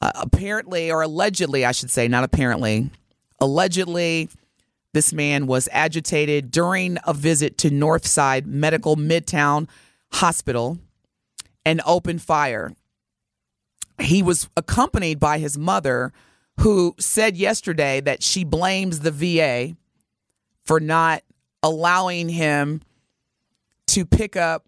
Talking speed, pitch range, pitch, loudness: 110 wpm, 145-175 Hz, 160 Hz, -20 LUFS